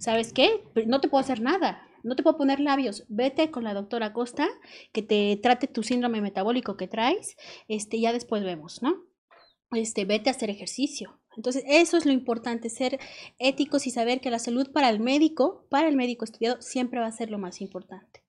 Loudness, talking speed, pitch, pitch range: -26 LUFS, 200 wpm, 245 Hz, 225-275 Hz